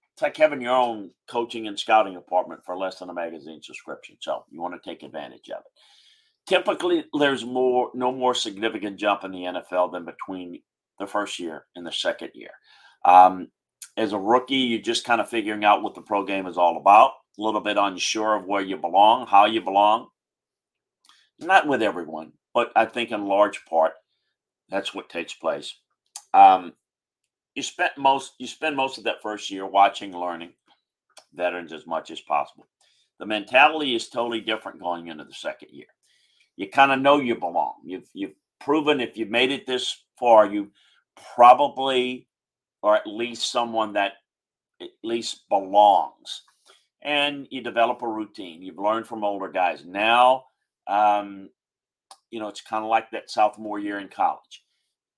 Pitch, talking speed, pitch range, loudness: 110 Hz, 175 wpm, 100-125 Hz, -22 LUFS